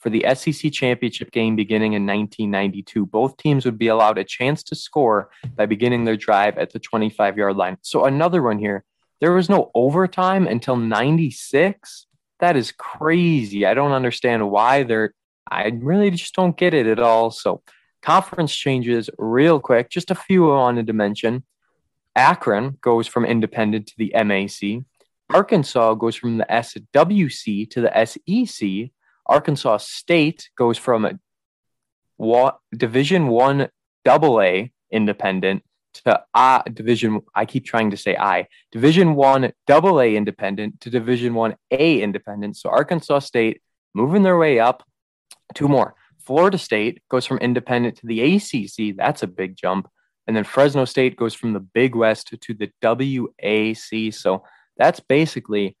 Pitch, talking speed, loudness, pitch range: 120 Hz, 155 wpm, -19 LUFS, 110-140 Hz